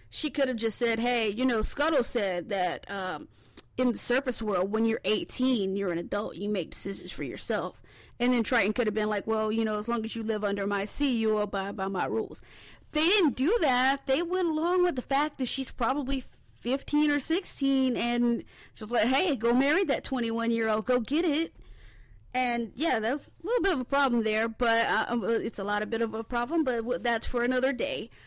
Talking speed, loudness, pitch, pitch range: 225 wpm, -28 LUFS, 240 Hz, 220-270 Hz